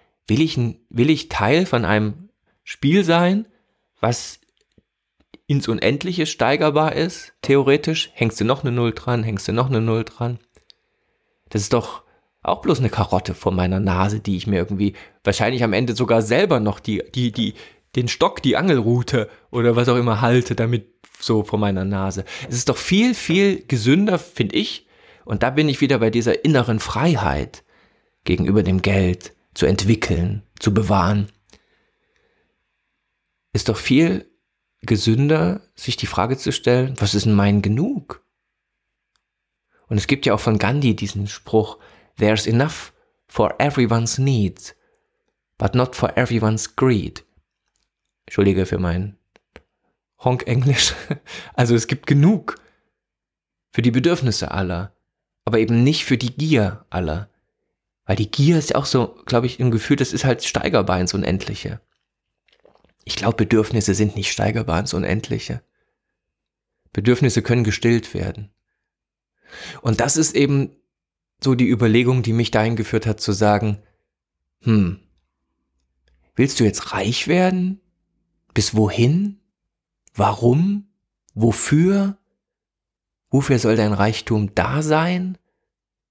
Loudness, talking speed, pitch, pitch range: -19 LUFS, 140 wpm, 115 Hz, 100-135 Hz